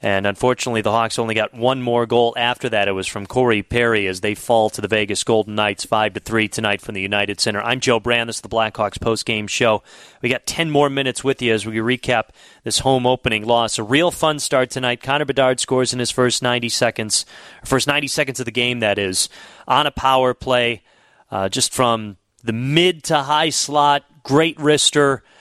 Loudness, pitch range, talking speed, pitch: -18 LUFS, 110-130 Hz, 215 wpm, 120 Hz